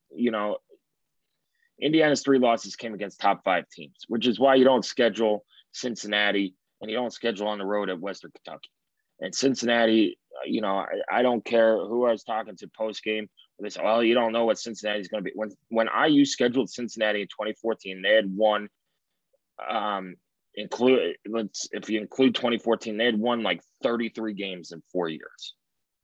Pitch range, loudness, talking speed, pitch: 105-120 Hz, -25 LUFS, 185 wpm, 115 Hz